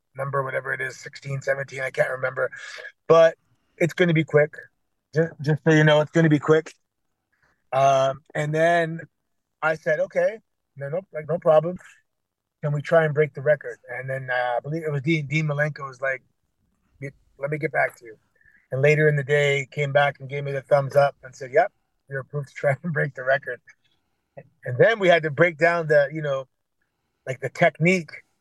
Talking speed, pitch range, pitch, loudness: 210 wpm, 135-160 Hz, 145 Hz, -22 LUFS